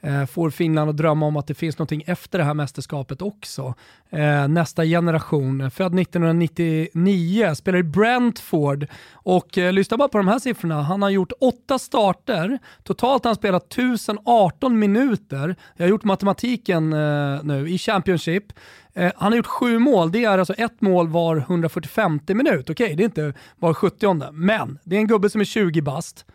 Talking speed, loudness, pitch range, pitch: 170 wpm, -21 LUFS, 155-210 Hz, 180 Hz